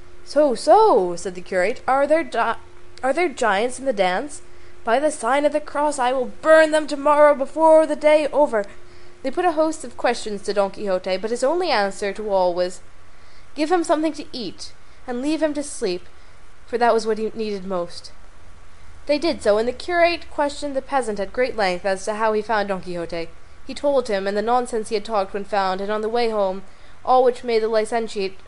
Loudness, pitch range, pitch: -21 LUFS, 200-295 Hz, 235 Hz